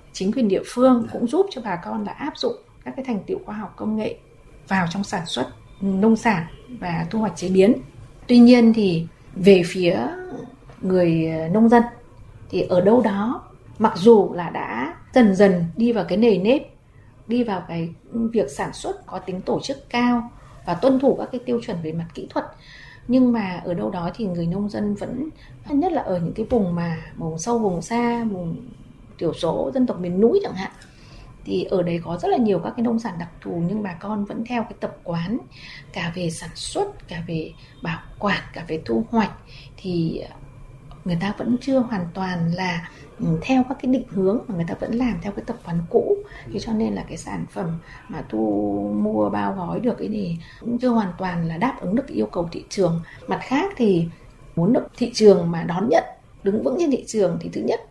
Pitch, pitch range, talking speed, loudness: 195 Hz, 170-235 Hz, 215 wpm, -22 LUFS